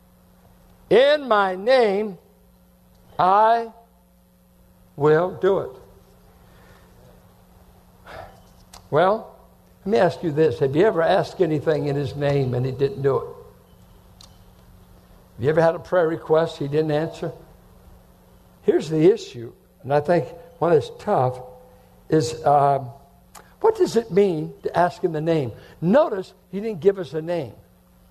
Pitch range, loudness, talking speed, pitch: 130-190 Hz, -21 LUFS, 135 wpm, 160 Hz